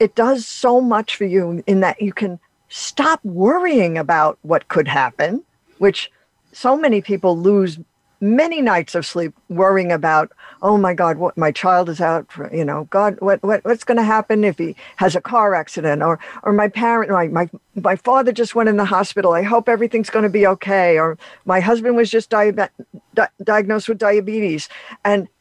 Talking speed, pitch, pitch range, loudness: 195 wpm, 200 Hz, 175-220 Hz, -17 LUFS